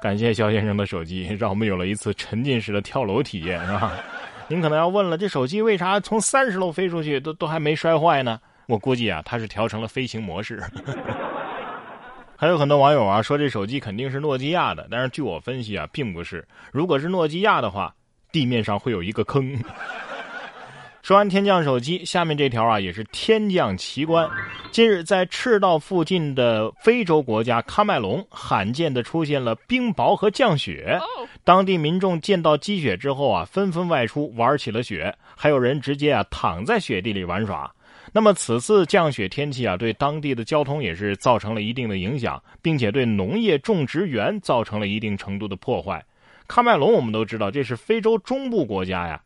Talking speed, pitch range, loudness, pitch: 295 characters per minute, 110-170 Hz, -22 LUFS, 135 Hz